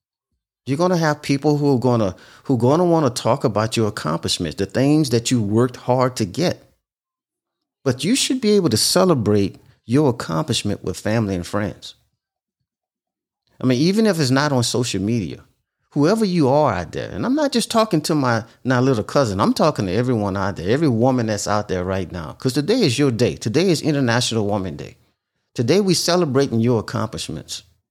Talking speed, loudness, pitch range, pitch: 190 wpm, -19 LUFS, 105-155 Hz, 125 Hz